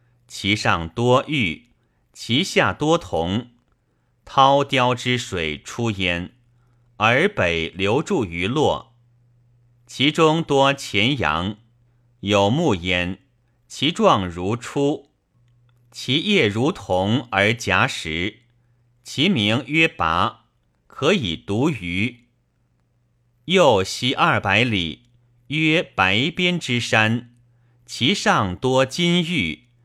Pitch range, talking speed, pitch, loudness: 105-130 Hz, 125 characters per minute, 120 Hz, -20 LUFS